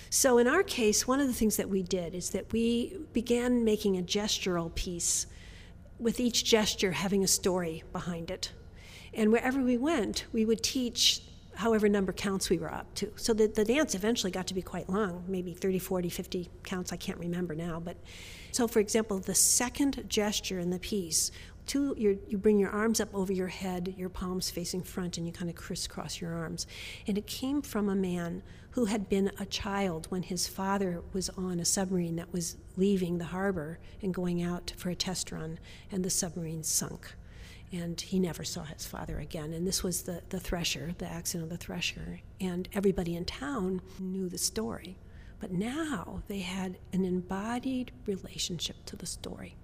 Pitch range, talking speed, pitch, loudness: 175-210 Hz, 195 wpm, 185 Hz, -31 LUFS